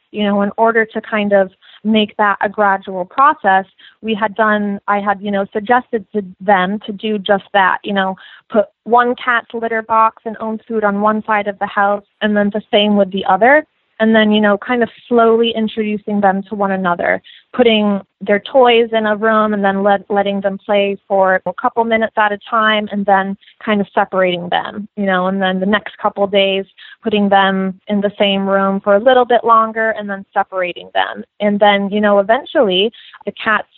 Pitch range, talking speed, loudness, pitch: 195-220 Hz, 210 wpm, -15 LUFS, 210 Hz